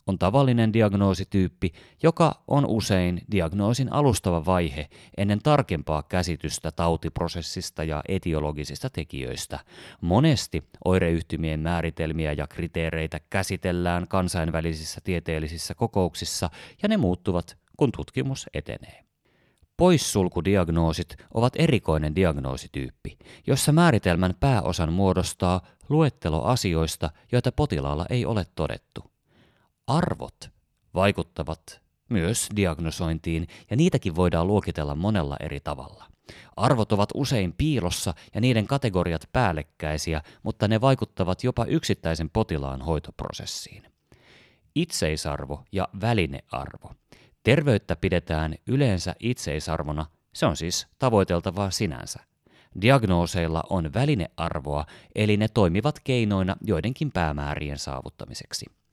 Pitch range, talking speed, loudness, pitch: 80-110 Hz, 95 wpm, -25 LUFS, 90 Hz